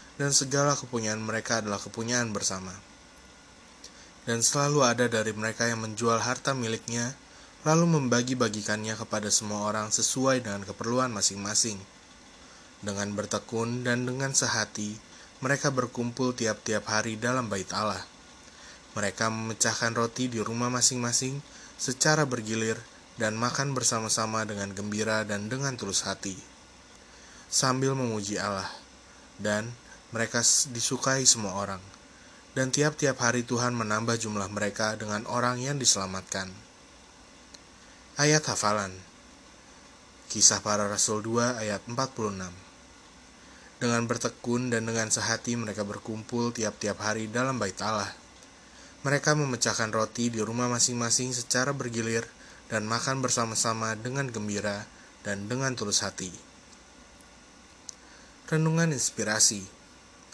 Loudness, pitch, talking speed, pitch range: -27 LUFS, 115 Hz, 110 wpm, 105-125 Hz